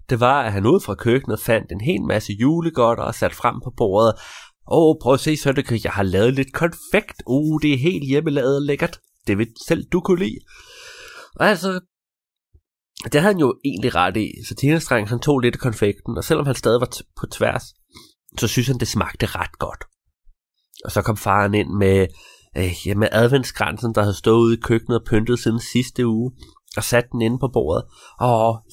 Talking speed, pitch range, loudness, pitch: 200 wpm, 110-145 Hz, -20 LUFS, 120 Hz